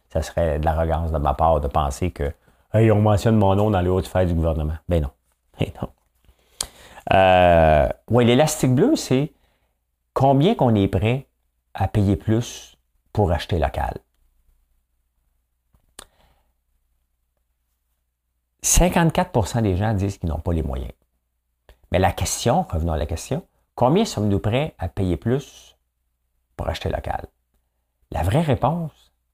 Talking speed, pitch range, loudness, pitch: 140 wpm, 65-105 Hz, -21 LUFS, 80 Hz